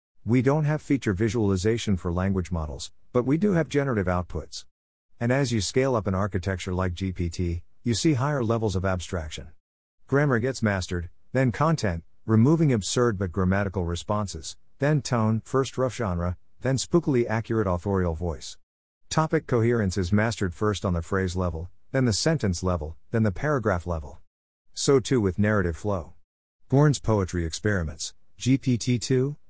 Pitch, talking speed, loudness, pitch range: 100 Hz, 155 wpm, -25 LUFS, 90-125 Hz